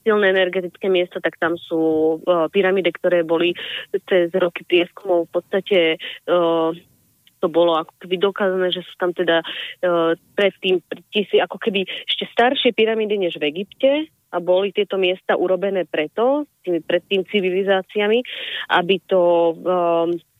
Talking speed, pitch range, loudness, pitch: 145 wpm, 170-200 Hz, -19 LUFS, 180 Hz